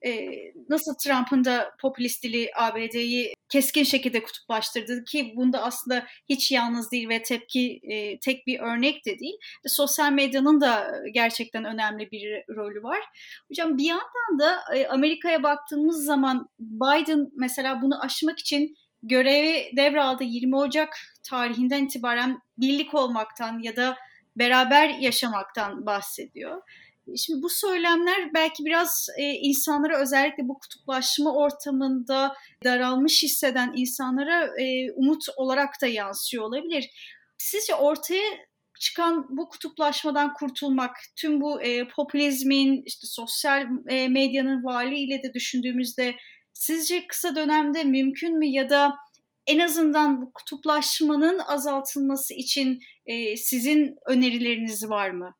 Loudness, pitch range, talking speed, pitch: -25 LUFS, 250-300 Hz, 115 wpm, 275 Hz